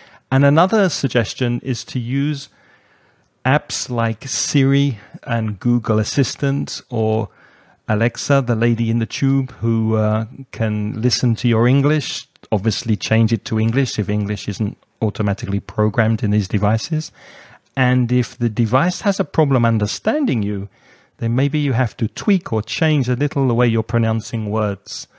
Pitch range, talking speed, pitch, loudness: 110-135 Hz, 150 wpm, 115 Hz, -18 LUFS